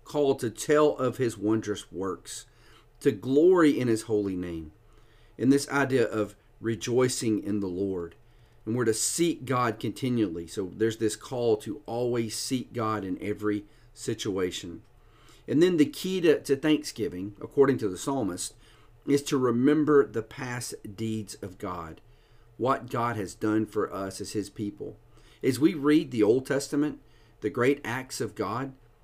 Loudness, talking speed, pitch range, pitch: -28 LUFS, 160 wpm, 110-140 Hz, 115 Hz